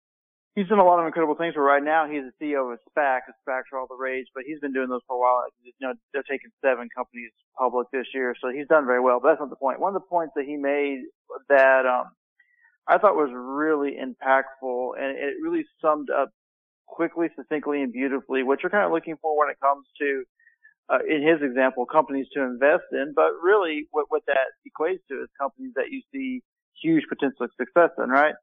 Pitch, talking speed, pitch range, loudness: 140 Hz, 225 wpm, 130-170 Hz, -24 LUFS